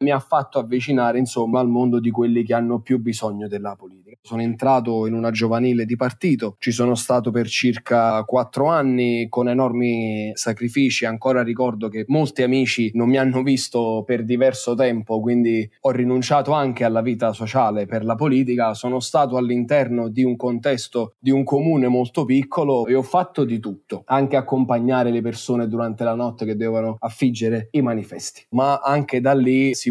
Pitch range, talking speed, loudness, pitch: 115-130 Hz, 175 wpm, -20 LUFS, 120 Hz